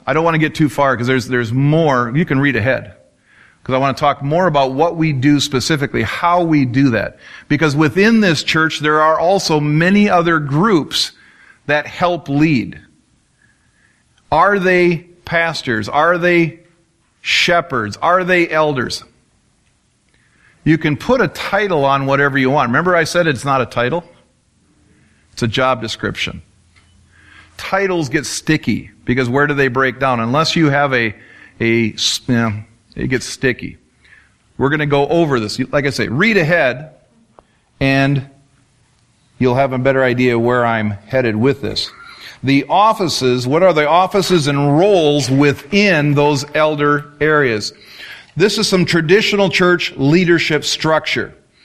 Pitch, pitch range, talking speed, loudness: 145 Hz, 125-165 Hz, 155 wpm, -15 LUFS